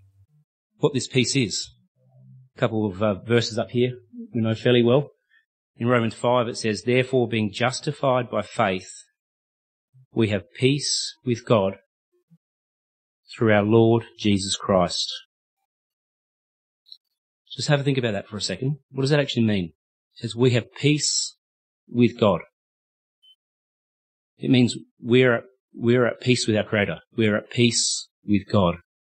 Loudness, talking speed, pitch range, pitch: -22 LUFS, 145 wpm, 105-130 Hz, 120 Hz